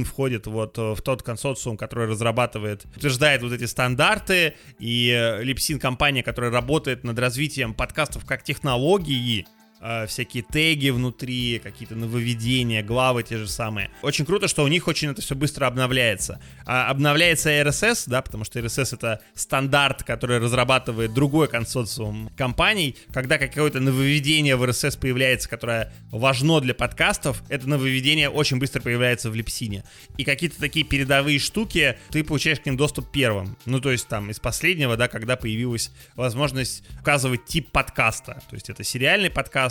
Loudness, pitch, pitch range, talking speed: -22 LUFS, 130 Hz, 115-145 Hz, 155 wpm